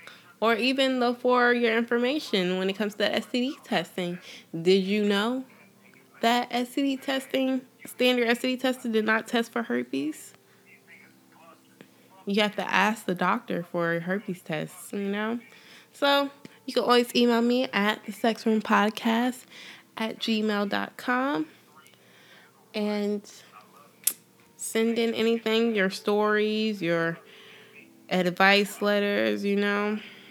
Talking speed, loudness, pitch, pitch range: 120 wpm, -26 LUFS, 215 Hz, 200-240 Hz